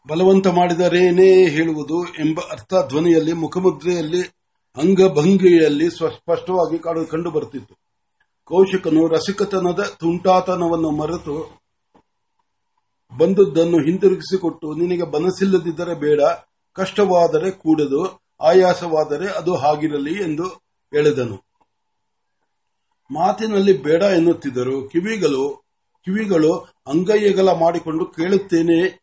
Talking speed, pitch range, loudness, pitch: 70 wpm, 160-190 Hz, -18 LUFS, 175 Hz